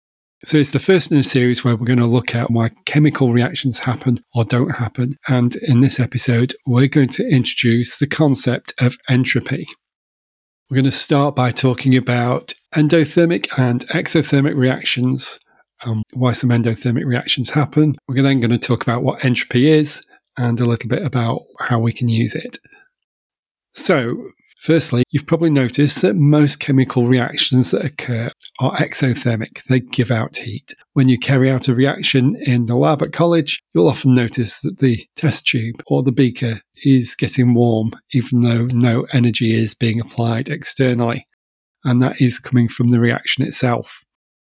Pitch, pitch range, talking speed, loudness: 125 Hz, 120-140 Hz, 170 wpm, -16 LUFS